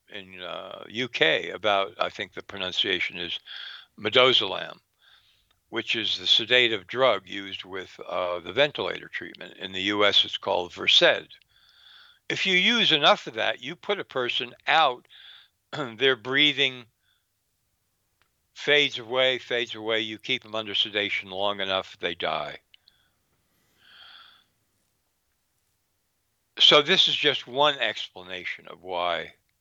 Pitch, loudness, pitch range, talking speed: 110 Hz, -23 LUFS, 95-135 Hz, 125 wpm